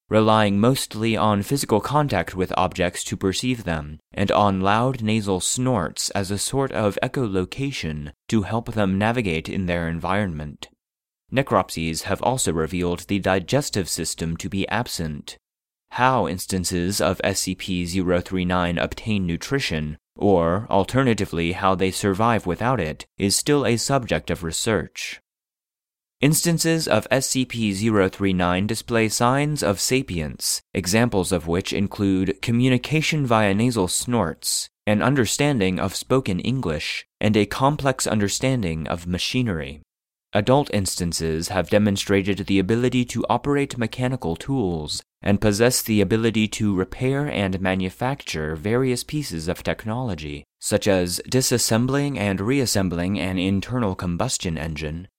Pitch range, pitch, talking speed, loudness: 90-120 Hz, 100 Hz, 125 wpm, -22 LUFS